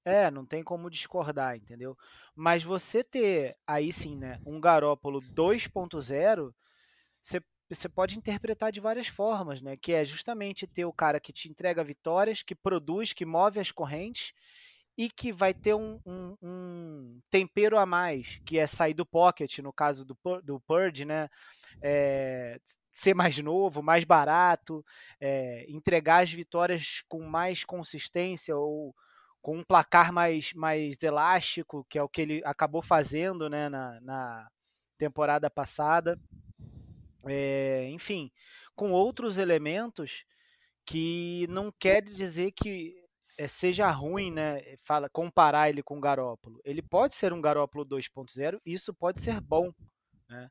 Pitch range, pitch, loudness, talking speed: 145-185 Hz, 165 Hz, -29 LUFS, 145 wpm